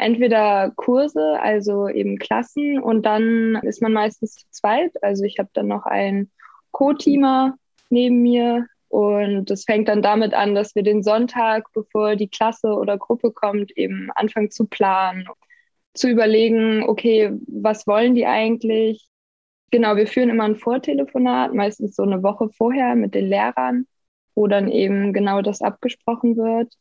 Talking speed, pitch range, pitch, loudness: 155 wpm, 205-240 Hz, 220 Hz, -19 LUFS